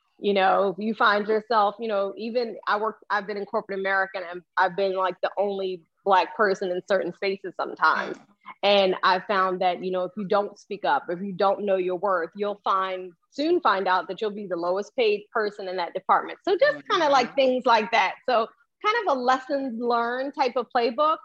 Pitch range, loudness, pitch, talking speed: 190-235 Hz, -24 LUFS, 205 Hz, 215 wpm